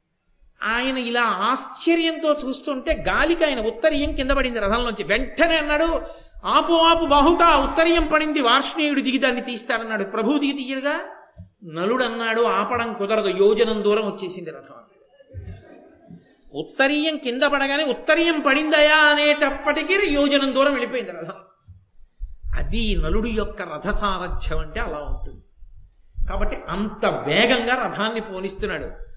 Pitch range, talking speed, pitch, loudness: 205-295 Hz, 105 wpm, 250 Hz, -20 LUFS